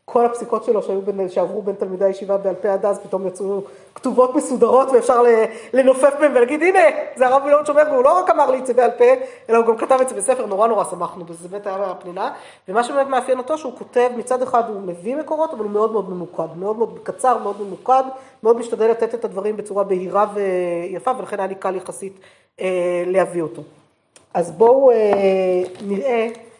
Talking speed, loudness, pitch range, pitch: 200 wpm, -18 LUFS, 195-255 Hz, 225 Hz